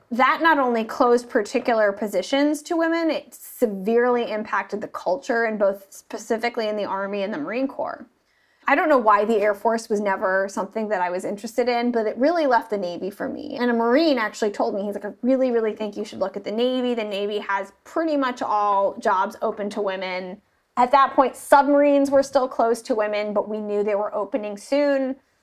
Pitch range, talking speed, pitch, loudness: 205-270 Hz, 210 wpm, 230 Hz, -22 LUFS